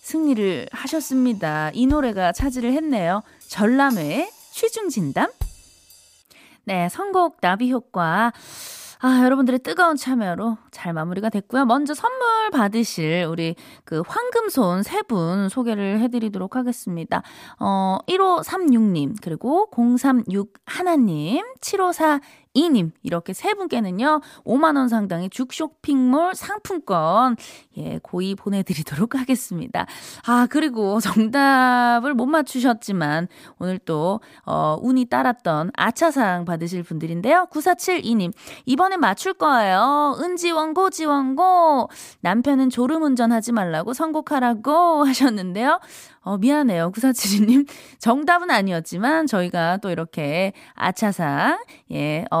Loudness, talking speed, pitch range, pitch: -21 LUFS, 250 characters per minute, 195-310 Hz, 250 Hz